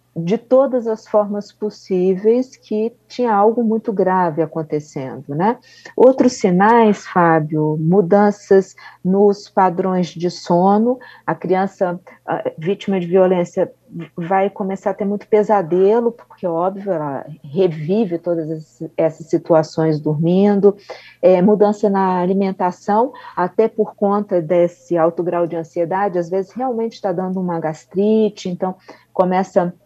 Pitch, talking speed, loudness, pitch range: 190 Hz, 125 wpm, -17 LUFS, 170-210 Hz